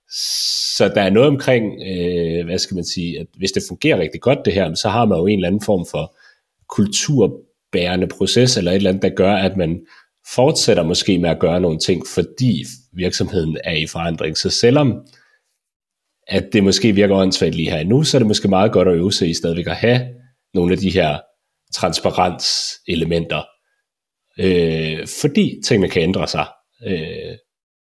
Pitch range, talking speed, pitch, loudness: 85-110 Hz, 180 wpm, 95 Hz, -17 LUFS